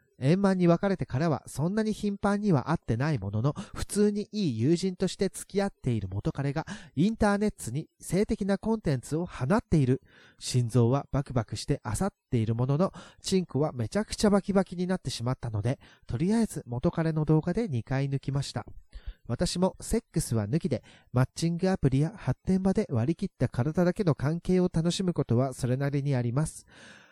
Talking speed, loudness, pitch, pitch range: 390 characters per minute, -29 LUFS, 155 Hz, 130-190 Hz